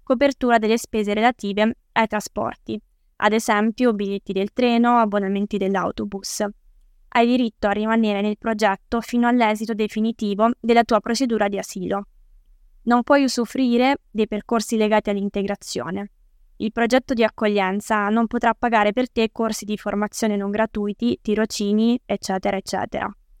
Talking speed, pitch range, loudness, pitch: 130 wpm, 205-235 Hz, -21 LUFS, 220 Hz